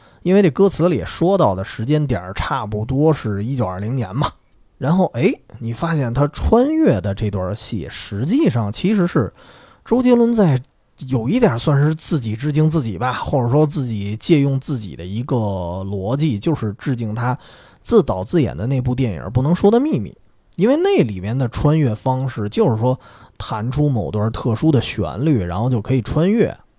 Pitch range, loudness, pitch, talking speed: 105-155 Hz, -18 LUFS, 130 Hz, 270 characters per minute